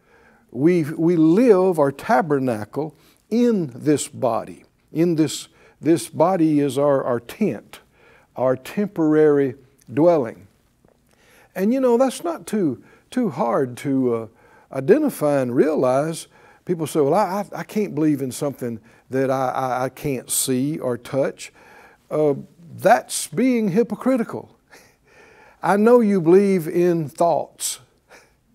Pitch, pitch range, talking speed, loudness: 155 Hz, 135-200 Hz, 125 wpm, -20 LUFS